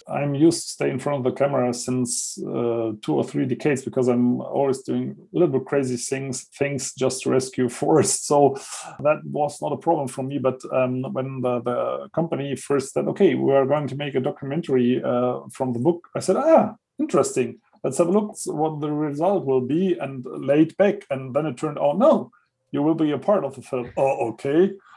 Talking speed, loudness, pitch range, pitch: 215 wpm, -23 LUFS, 130-155 Hz, 140 Hz